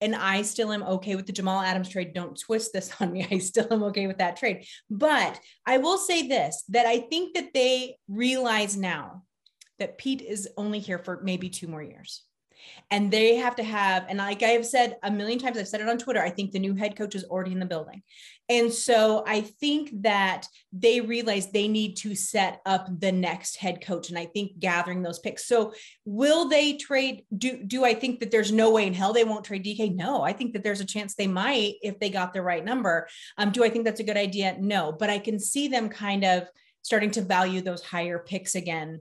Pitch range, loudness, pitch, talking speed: 190-230 Hz, -26 LUFS, 210 Hz, 230 wpm